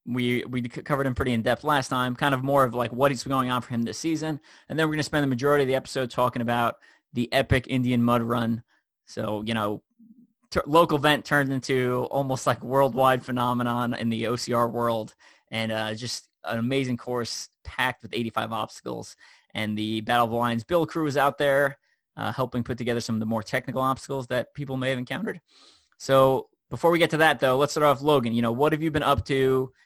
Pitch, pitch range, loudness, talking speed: 130 Hz, 120-140 Hz, -25 LUFS, 225 wpm